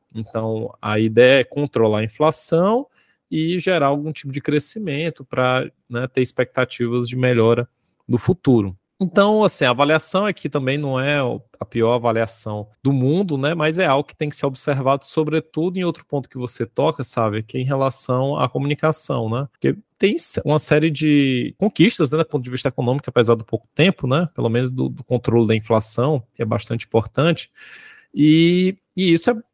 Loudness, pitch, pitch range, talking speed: -19 LUFS, 135 Hz, 120-155 Hz, 185 wpm